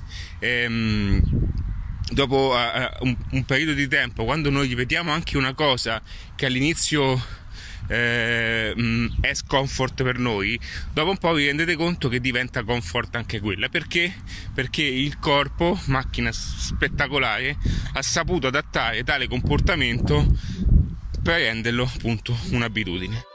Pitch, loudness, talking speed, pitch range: 120 Hz, -23 LUFS, 110 wpm, 105-140 Hz